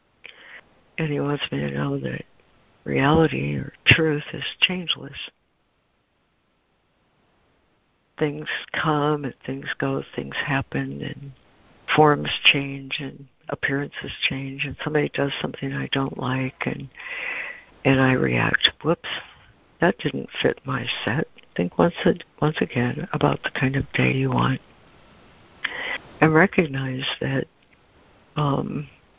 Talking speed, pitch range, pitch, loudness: 120 wpm, 125-150 Hz, 135 Hz, -23 LUFS